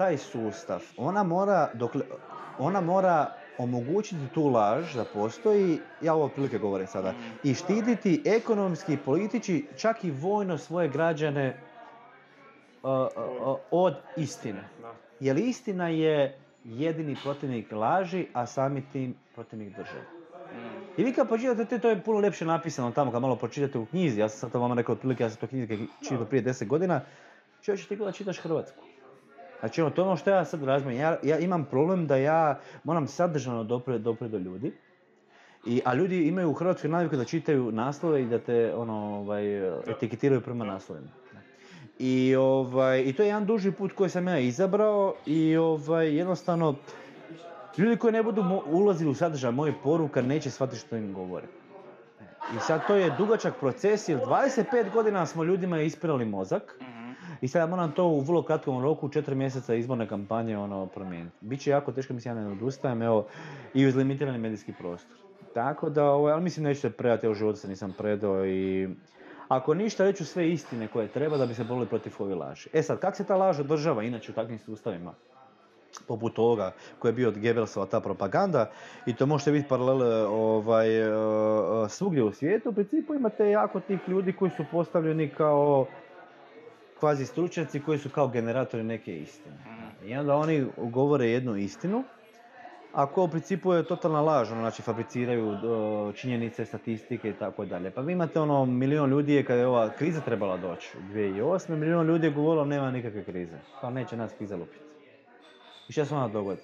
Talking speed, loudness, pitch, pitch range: 175 wpm, -28 LUFS, 140 Hz, 115-170 Hz